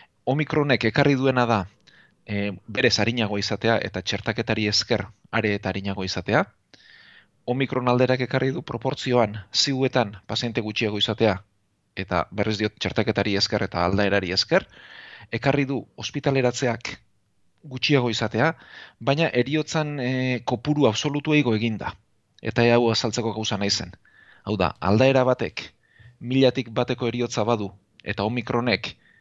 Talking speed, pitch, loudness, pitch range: 120 wpm, 115 Hz, -23 LUFS, 105-130 Hz